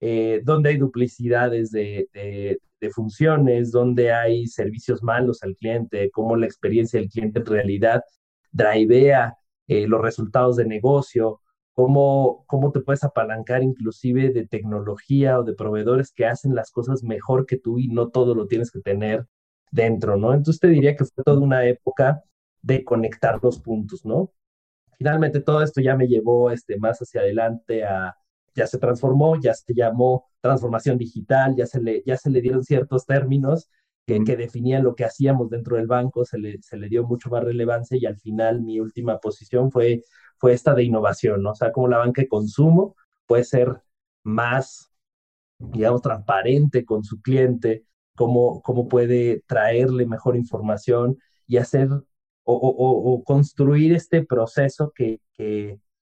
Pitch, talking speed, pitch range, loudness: 120 Hz, 165 wpm, 110-130 Hz, -21 LUFS